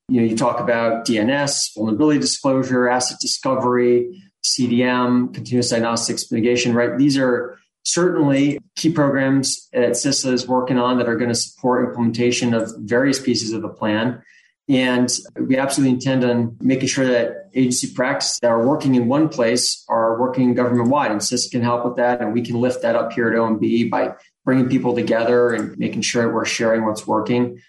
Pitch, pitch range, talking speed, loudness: 125 Hz, 115-130 Hz, 180 wpm, -19 LUFS